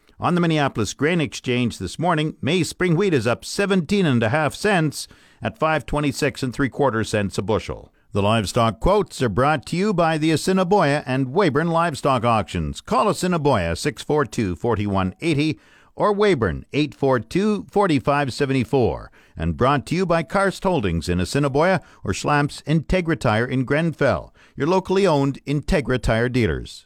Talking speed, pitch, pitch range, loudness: 145 wpm, 145 Hz, 120-165 Hz, -21 LUFS